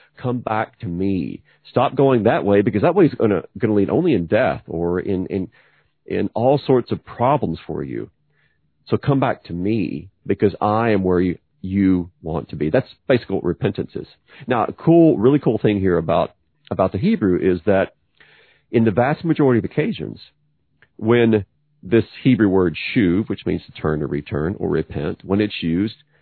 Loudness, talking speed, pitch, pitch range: -19 LUFS, 190 wpm, 105 Hz, 90-120 Hz